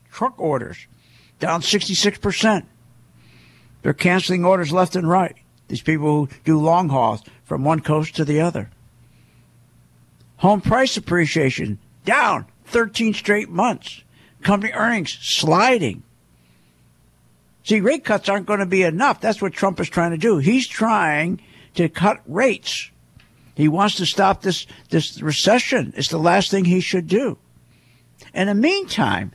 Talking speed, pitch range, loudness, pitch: 140 wpm, 130-205 Hz, -19 LUFS, 175 Hz